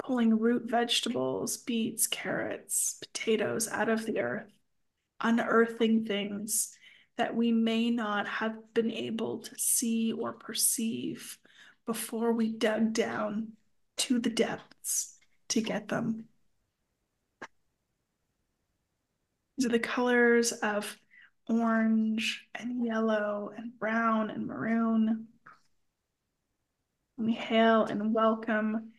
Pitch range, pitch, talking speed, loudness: 220-235 Hz, 225 Hz, 100 wpm, -30 LUFS